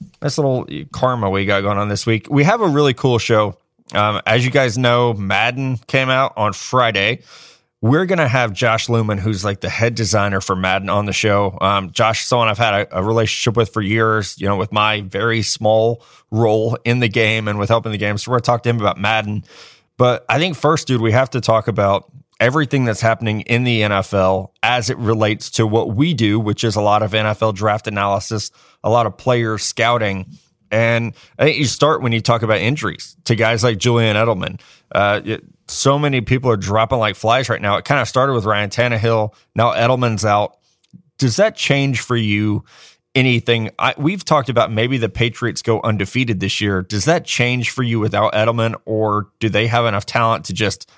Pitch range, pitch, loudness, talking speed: 105-125 Hz, 115 Hz, -17 LUFS, 210 wpm